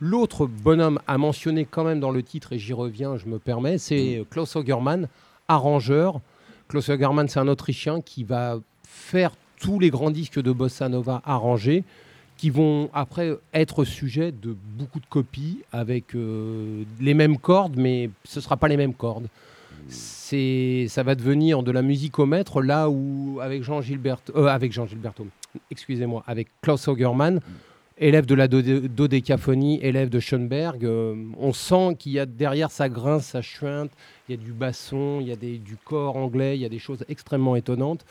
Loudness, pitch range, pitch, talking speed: -23 LUFS, 125-150 Hz, 135 Hz, 185 wpm